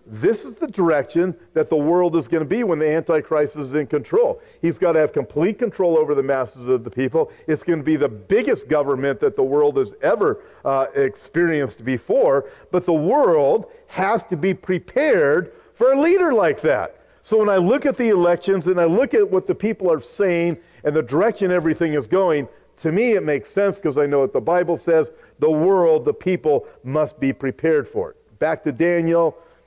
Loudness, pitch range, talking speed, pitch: -19 LUFS, 150-210 Hz, 205 wpm, 170 Hz